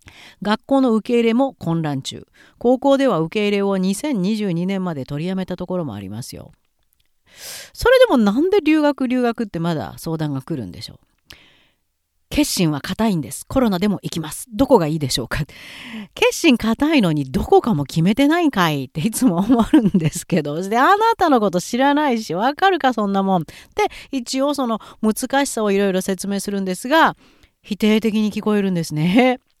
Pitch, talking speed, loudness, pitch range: 210 Hz, 355 characters per minute, -18 LUFS, 170-260 Hz